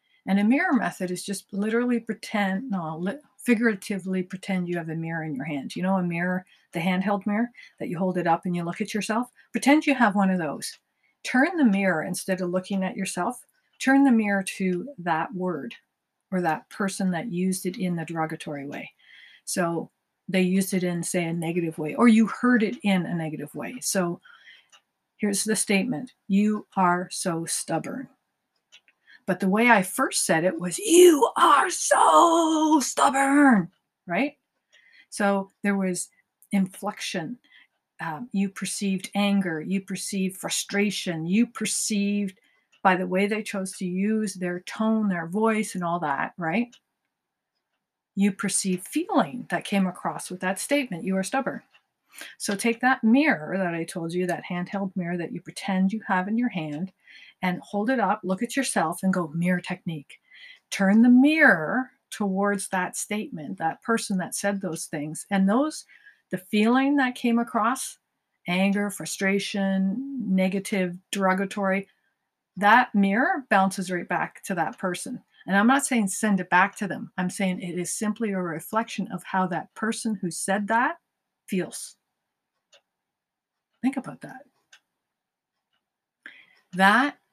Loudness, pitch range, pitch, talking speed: -25 LUFS, 180-225 Hz, 195 Hz, 160 wpm